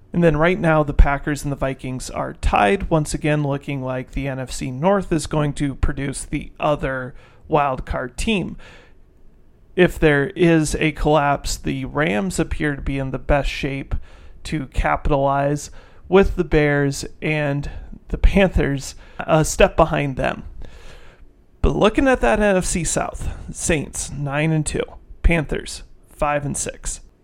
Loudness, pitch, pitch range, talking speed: -20 LUFS, 145 Hz, 135-160 Hz, 145 wpm